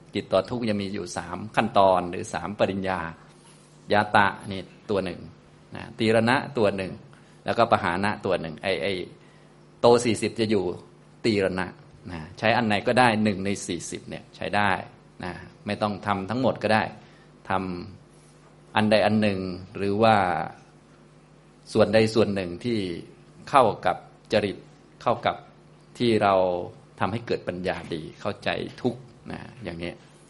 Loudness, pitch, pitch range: -25 LUFS, 105 Hz, 95-115 Hz